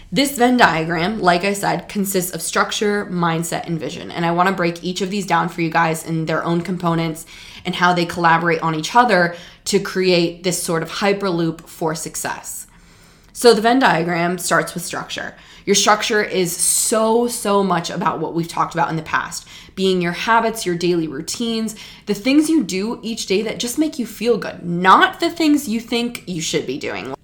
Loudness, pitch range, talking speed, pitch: -18 LUFS, 170-220 Hz, 200 wpm, 180 Hz